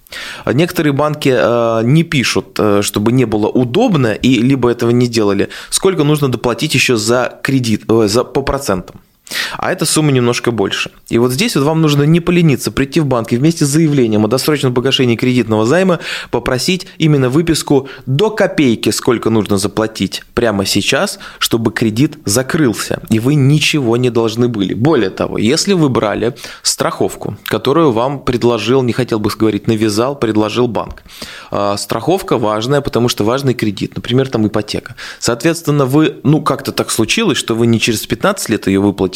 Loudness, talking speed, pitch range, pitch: -13 LUFS, 160 wpm, 110-145 Hz, 125 Hz